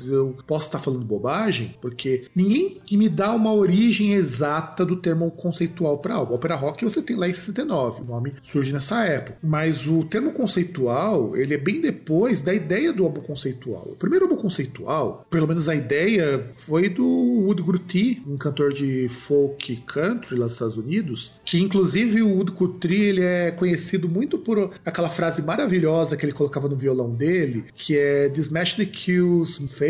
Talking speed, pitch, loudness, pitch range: 175 wpm, 165 Hz, -22 LUFS, 140-195 Hz